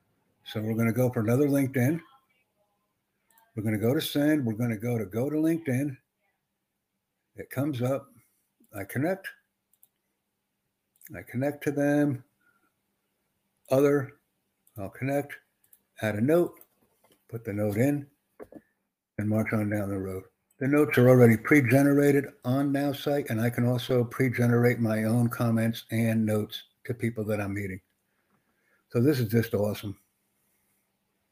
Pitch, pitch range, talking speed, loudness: 120 Hz, 110-145 Hz, 145 wpm, -27 LUFS